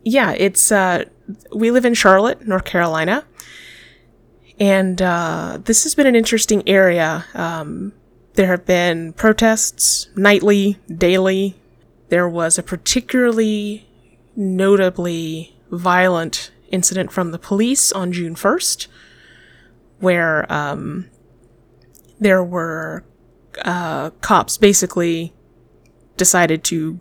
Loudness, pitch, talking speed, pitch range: -16 LUFS, 185 Hz, 100 wpm, 170-205 Hz